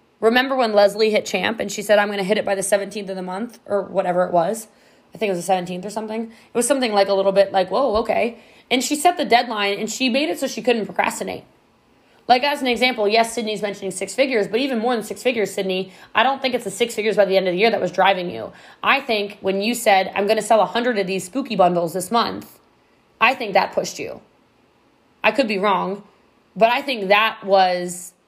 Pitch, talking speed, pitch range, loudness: 210 Hz, 250 wpm, 195-235 Hz, -20 LUFS